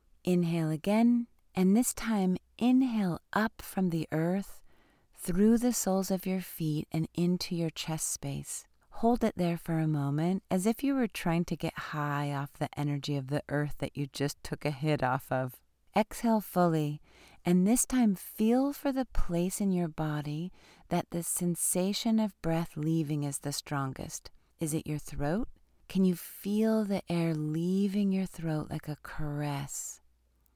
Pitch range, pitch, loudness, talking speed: 150-195 Hz, 170 Hz, -31 LUFS, 165 wpm